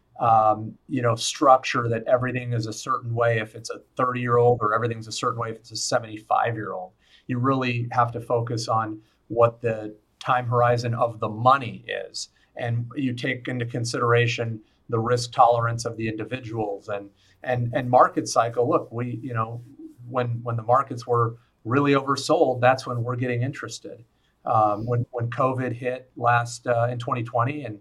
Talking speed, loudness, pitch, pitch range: 180 wpm, -24 LUFS, 120 Hz, 115-125 Hz